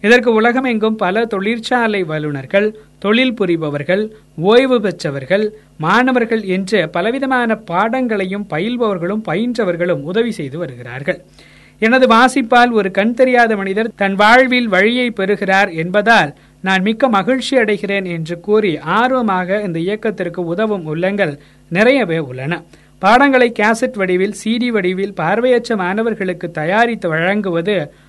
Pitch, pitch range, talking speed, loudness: 205 Hz, 180-230 Hz, 110 wpm, -15 LUFS